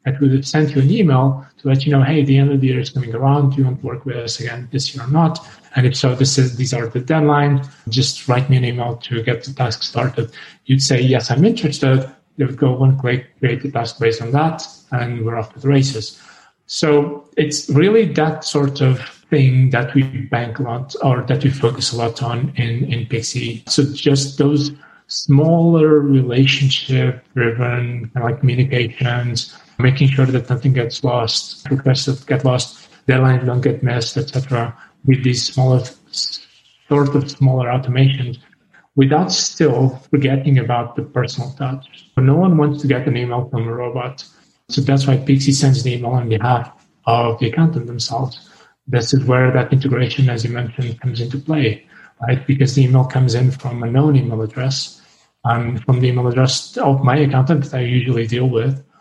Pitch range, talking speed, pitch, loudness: 125-140 Hz, 195 wpm, 130 Hz, -17 LUFS